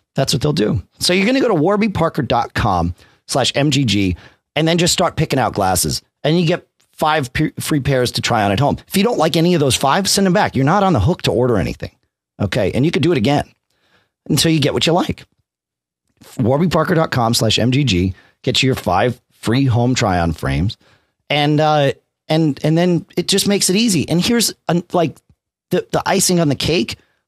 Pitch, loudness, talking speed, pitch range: 145 Hz, -16 LUFS, 200 wpm, 120-170 Hz